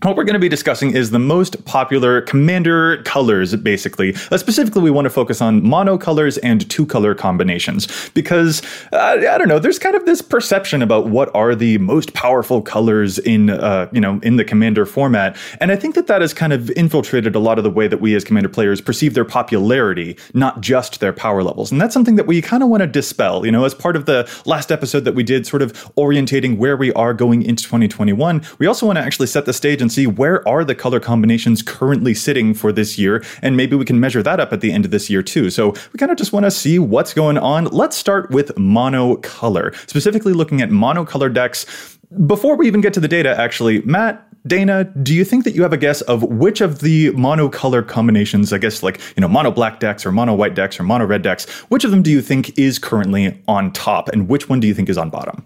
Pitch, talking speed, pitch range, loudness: 140 Hz, 240 wpm, 115-180 Hz, -15 LUFS